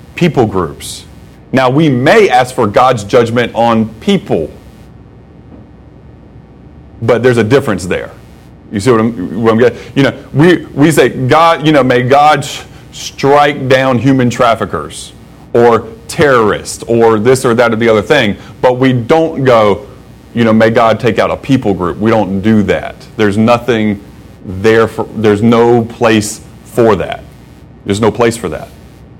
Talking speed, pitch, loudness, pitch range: 160 wpm, 115 Hz, -10 LUFS, 110-130 Hz